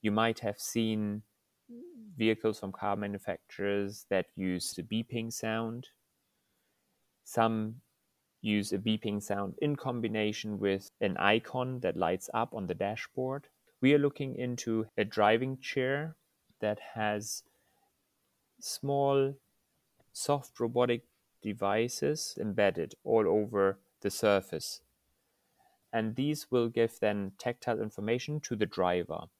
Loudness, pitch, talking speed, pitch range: -32 LUFS, 110 Hz, 115 wpm, 100-125 Hz